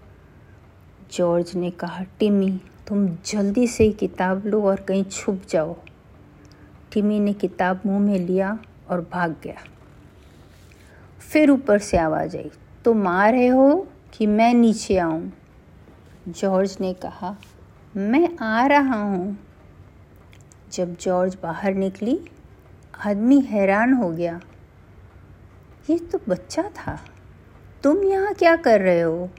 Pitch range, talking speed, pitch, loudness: 170-220 Hz, 125 wpm, 195 Hz, -21 LUFS